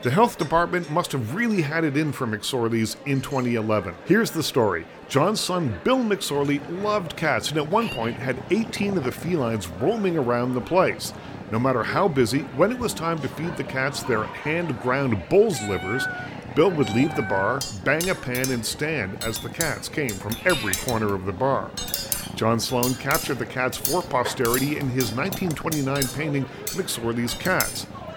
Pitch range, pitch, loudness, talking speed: 120-165 Hz, 135 Hz, -24 LUFS, 180 wpm